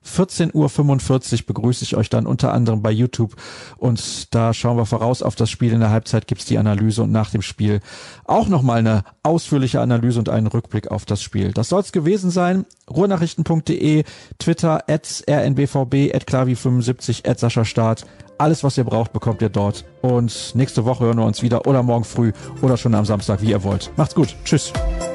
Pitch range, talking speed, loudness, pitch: 110-140 Hz, 185 wpm, -19 LUFS, 120 Hz